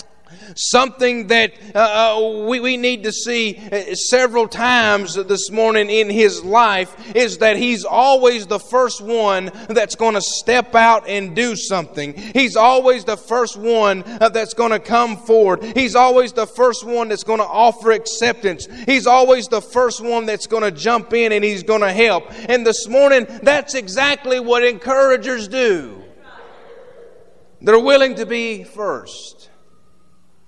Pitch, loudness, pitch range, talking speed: 230 Hz, -15 LUFS, 215-250 Hz, 155 wpm